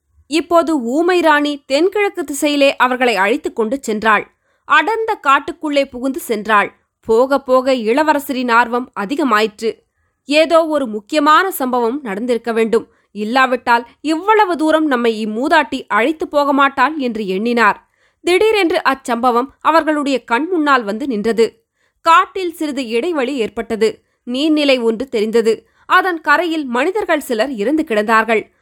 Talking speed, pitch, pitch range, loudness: 115 wpm, 270 Hz, 235-315 Hz, -15 LUFS